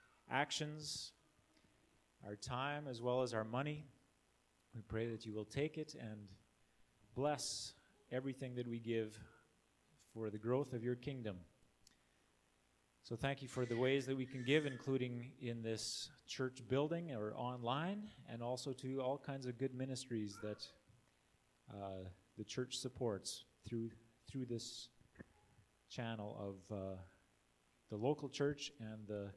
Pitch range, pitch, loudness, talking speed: 110-135 Hz, 120 Hz, -44 LUFS, 140 wpm